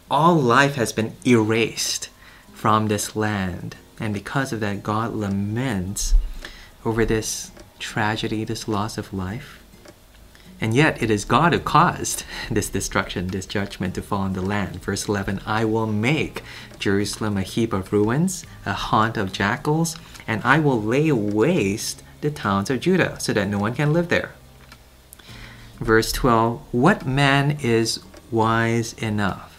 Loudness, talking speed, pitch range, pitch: -22 LUFS, 150 wpm, 100-120 Hz, 110 Hz